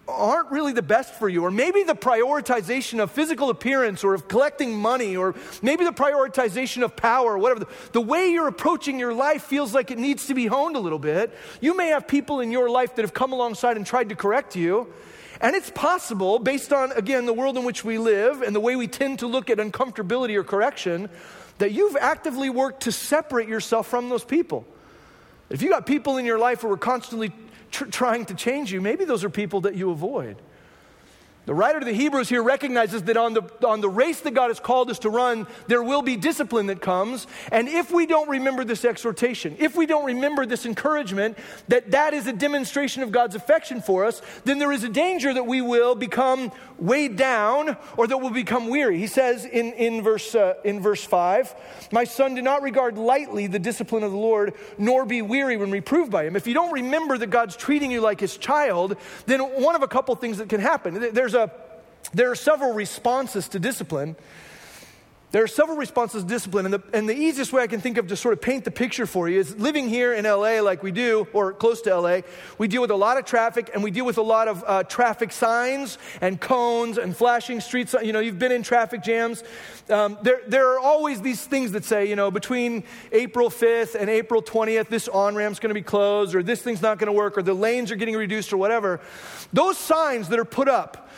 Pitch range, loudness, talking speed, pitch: 215-265 Hz, -23 LUFS, 225 wpm, 240 Hz